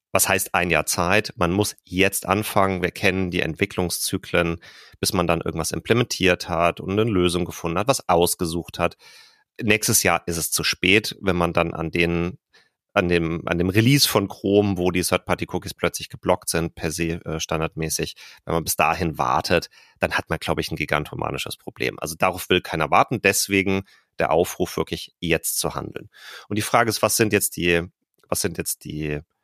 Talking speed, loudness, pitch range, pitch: 190 wpm, -22 LUFS, 85-100 Hz, 90 Hz